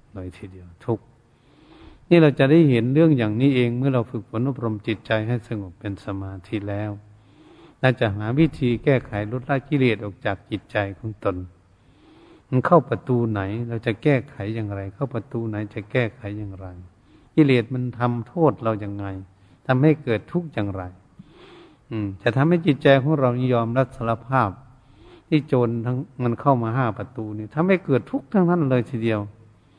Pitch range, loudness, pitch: 105-135 Hz, -22 LUFS, 115 Hz